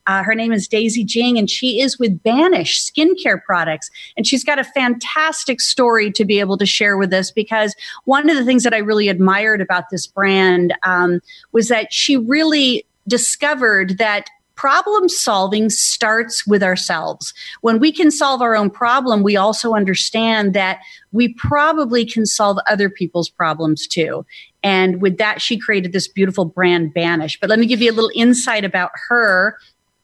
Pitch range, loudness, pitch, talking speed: 195-250 Hz, -15 LUFS, 220 Hz, 175 wpm